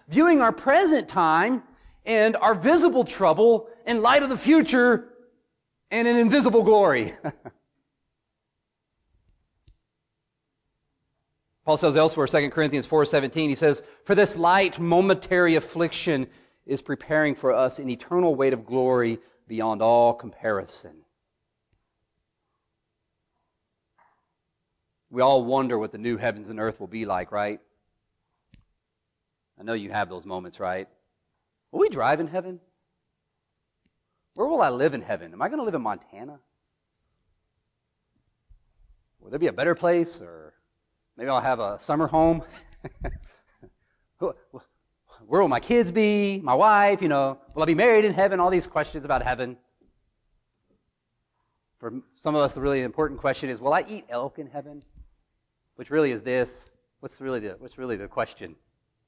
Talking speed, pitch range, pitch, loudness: 140 wpm, 125-195 Hz, 150 Hz, -23 LUFS